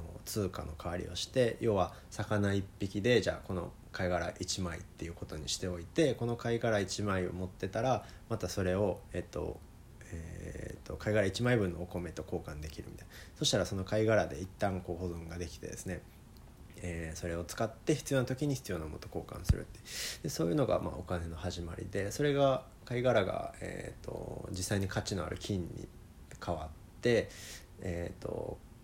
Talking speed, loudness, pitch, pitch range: 345 characters per minute, -35 LUFS, 95 Hz, 85-110 Hz